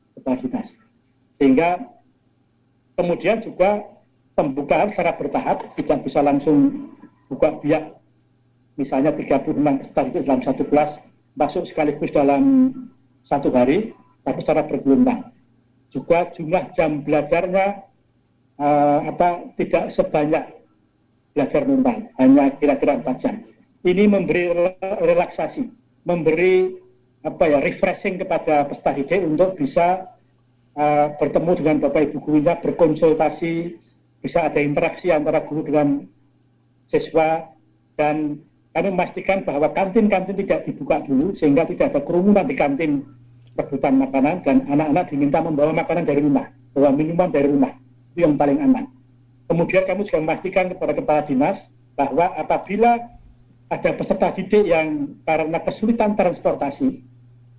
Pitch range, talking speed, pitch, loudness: 140-185 Hz, 115 wpm, 155 Hz, -20 LUFS